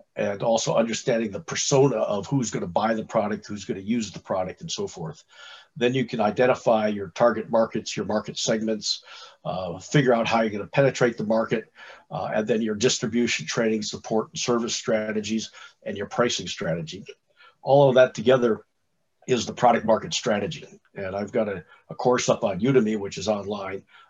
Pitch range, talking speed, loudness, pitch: 110-130 Hz, 180 wpm, -24 LUFS, 115 Hz